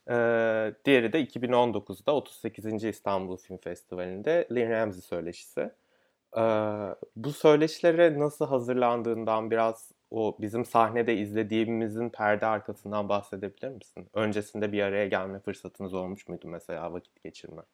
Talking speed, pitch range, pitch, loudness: 120 wpm, 100-120 Hz, 110 Hz, -28 LUFS